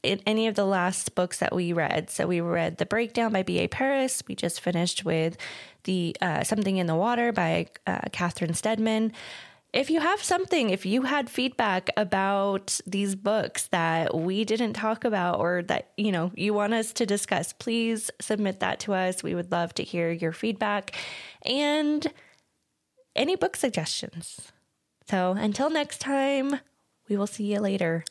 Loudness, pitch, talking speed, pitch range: -27 LUFS, 205 Hz, 175 wpm, 180-235 Hz